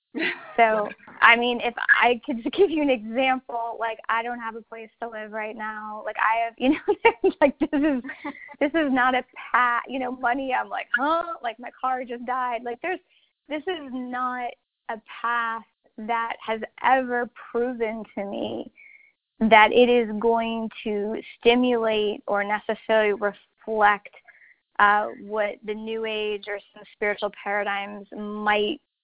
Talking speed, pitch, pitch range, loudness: 160 wpm, 230 Hz, 215-260 Hz, -24 LUFS